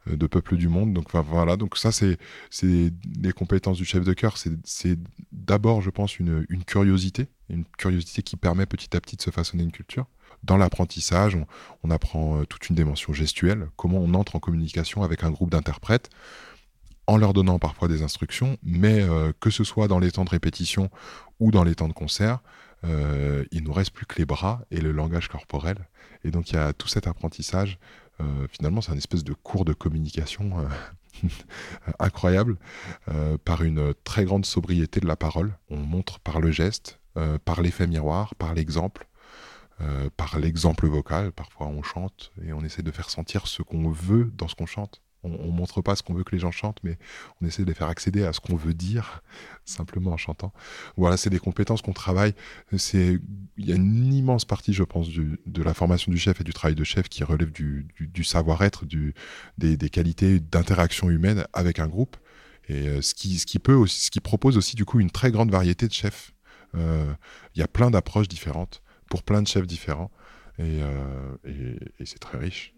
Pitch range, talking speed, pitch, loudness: 80-100 Hz, 210 wpm, 90 Hz, -25 LUFS